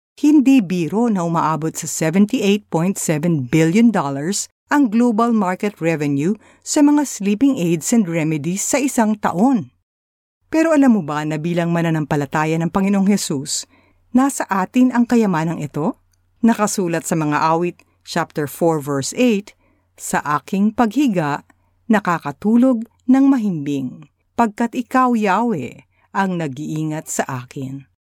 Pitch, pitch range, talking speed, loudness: 175 Hz, 155-230 Hz, 120 wpm, -18 LUFS